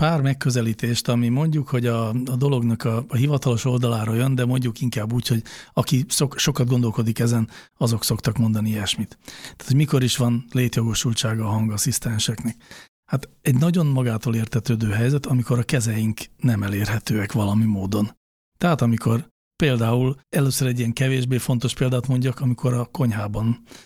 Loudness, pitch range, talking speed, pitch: -22 LUFS, 115-130 Hz, 155 wpm, 120 Hz